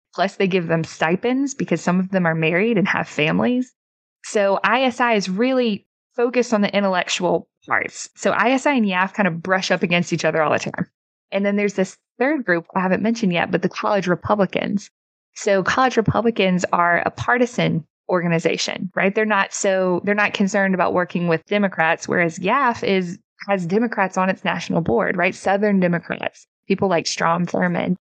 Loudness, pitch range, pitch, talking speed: -20 LUFS, 175-210 Hz, 195 Hz, 180 wpm